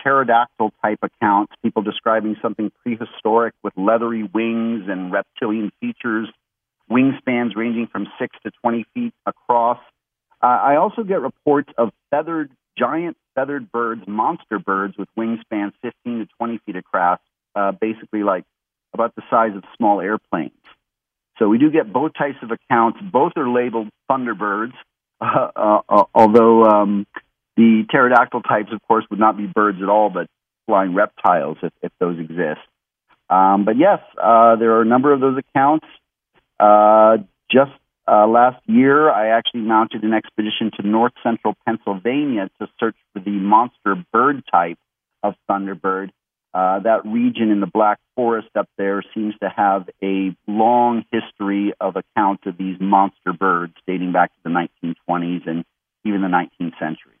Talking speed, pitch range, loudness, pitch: 155 wpm, 100-120 Hz, -18 LUFS, 110 Hz